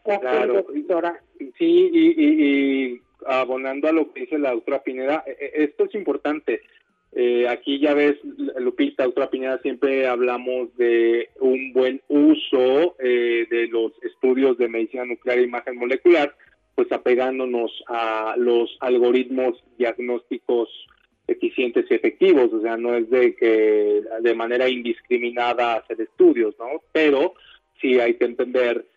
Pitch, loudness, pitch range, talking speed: 130 Hz, -21 LUFS, 120-170 Hz, 135 wpm